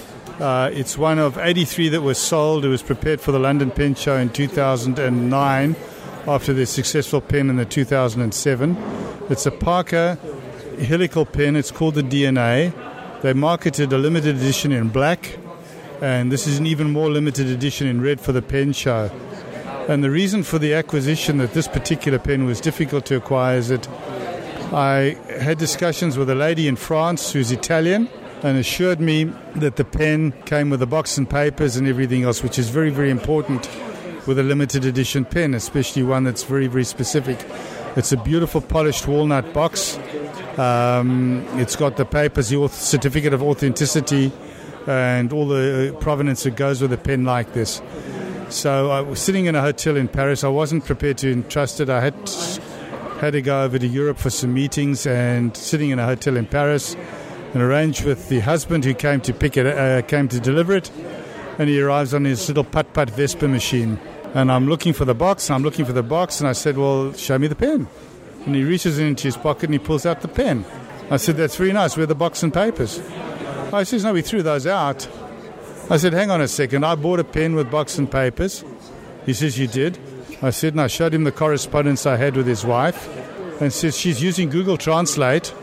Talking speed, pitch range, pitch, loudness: 200 wpm, 130-155 Hz, 145 Hz, -20 LUFS